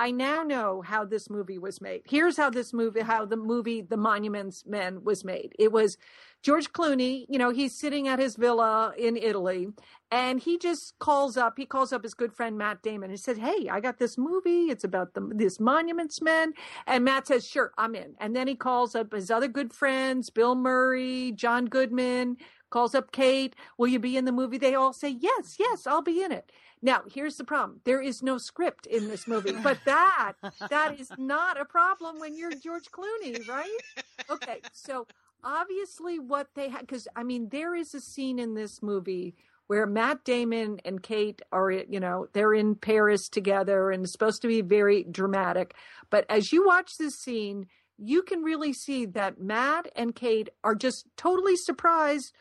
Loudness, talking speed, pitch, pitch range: -27 LUFS, 195 wpm, 255 Hz, 215-295 Hz